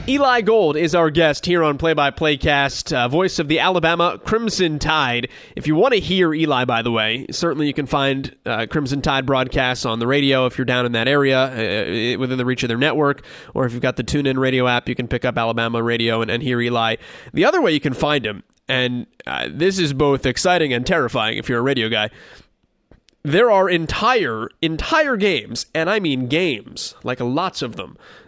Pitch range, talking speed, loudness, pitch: 125-160 Hz, 215 wpm, -19 LUFS, 140 Hz